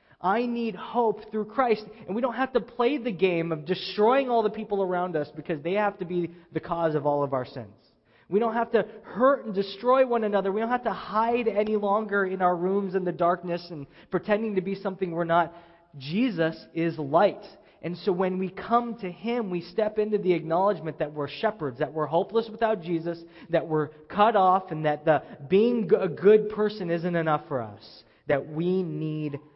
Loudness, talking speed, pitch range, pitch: -26 LUFS, 205 wpm, 165-215 Hz, 185 Hz